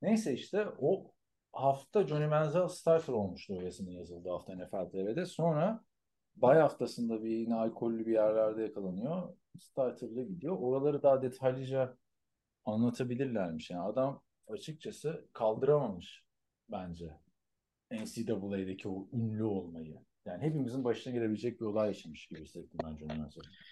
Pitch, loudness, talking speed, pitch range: 115 Hz, -34 LUFS, 125 wpm, 100-140 Hz